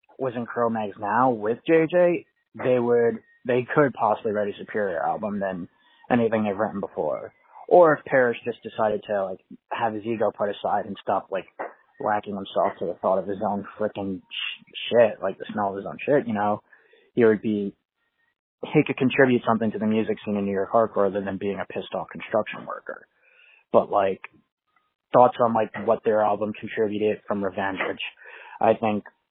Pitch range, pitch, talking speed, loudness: 100-125 Hz, 110 Hz, 190 wpm, -24 LUFS